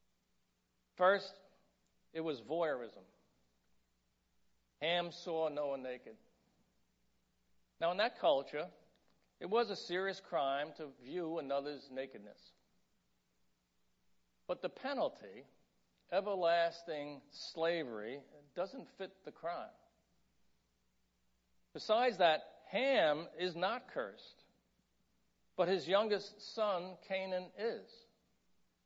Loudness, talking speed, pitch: -38 LUFS, 85 wpm, 150 Hz